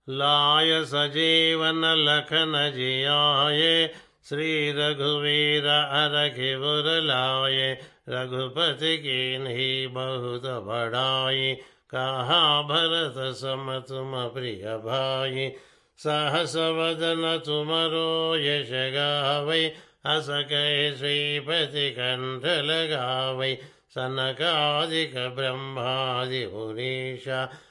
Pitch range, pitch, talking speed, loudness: 130-155 Hz, 145 Hz, 65 wpm, -24 LUFS